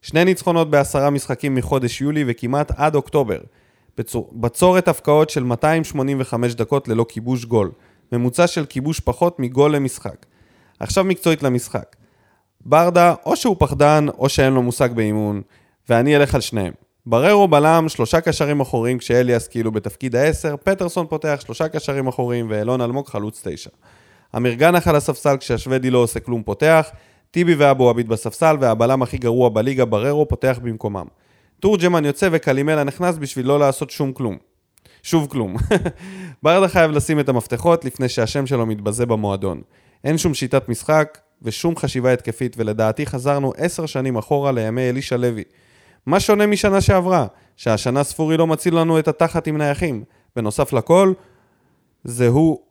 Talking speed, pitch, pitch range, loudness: 150 wpm, 135 Hz, 120-155 Hz, -18 LUFS